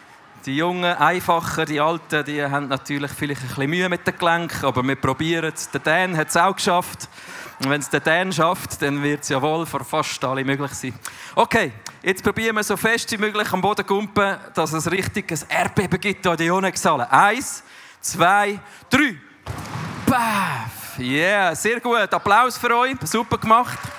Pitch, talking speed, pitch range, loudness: 170 Hz, 180 wpm, 145-200 Hz, -20 LUFS